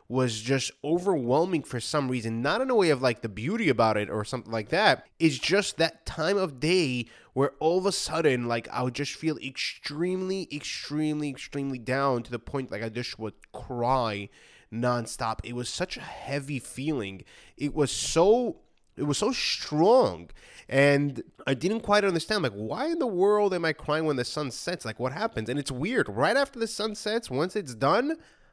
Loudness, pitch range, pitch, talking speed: -27 LUFS, 120-175 Hz, 140 Hz, 195 wpm